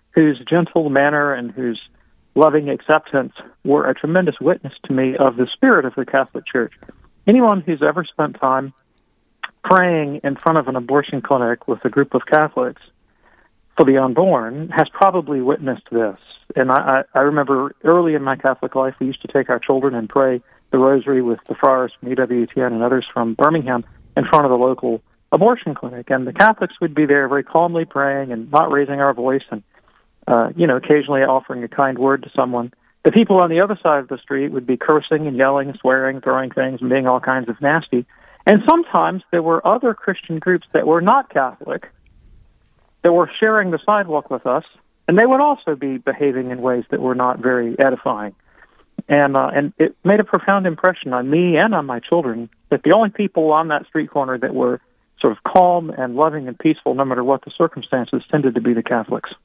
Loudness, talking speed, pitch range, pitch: -17 LUFS, 200 wpm, 130-165 Hz, 140 Hz